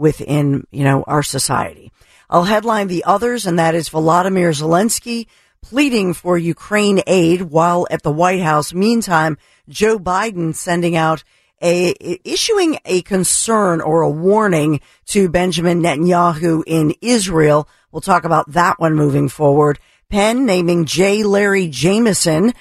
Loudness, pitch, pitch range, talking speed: -15 LUFS, 175 Hz, 160-200 Hz, 140 wpm